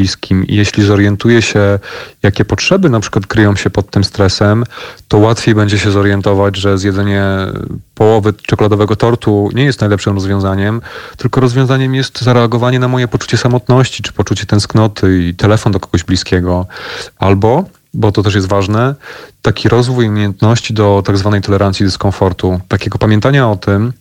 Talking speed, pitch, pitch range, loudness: 150 wpm, 105 Hz, 100-115 Hz, -11 LUFS